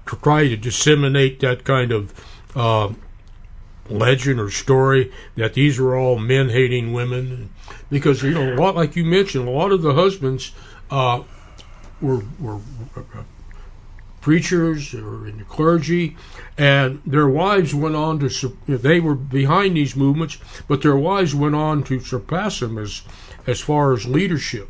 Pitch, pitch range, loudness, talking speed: 130 Hz, 110-150 Hz, -18 LUFS, 160 wpm